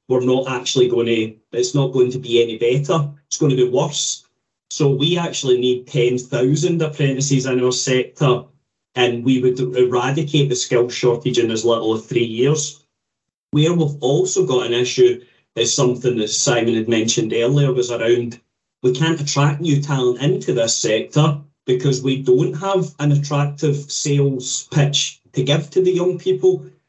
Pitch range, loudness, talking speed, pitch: 125-145 Hz, -18 LUFS, 170 wpm, 130 Hz